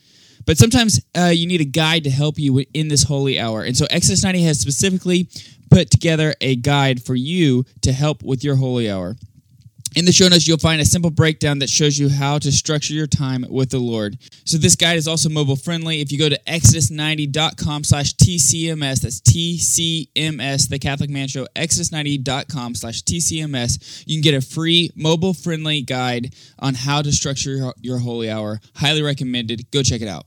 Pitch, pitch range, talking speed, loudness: 145 Hz, 130-160 Hz, 190 wpm, -17 LUFS